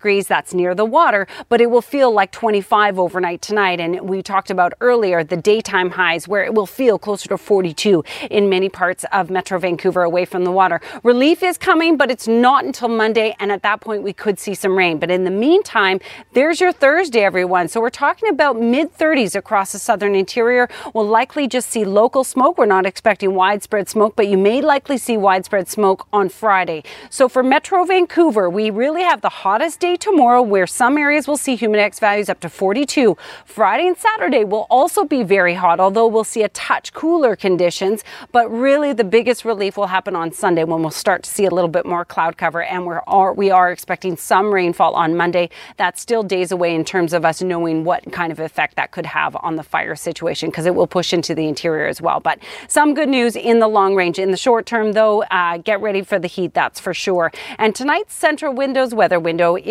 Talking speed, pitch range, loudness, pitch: 220 wpm, 180-245 Hz, -16 LUFS, 205 Hz